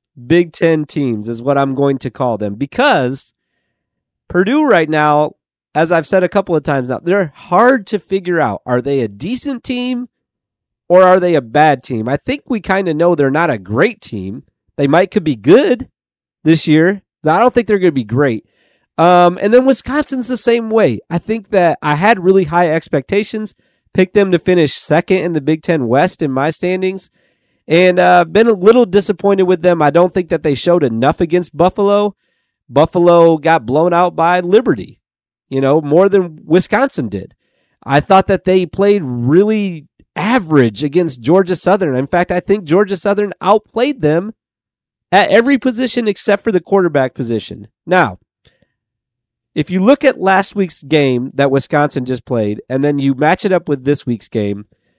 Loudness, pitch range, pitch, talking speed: -13 LUFS, 140-195 Hz, 175 Hz, 185 wpm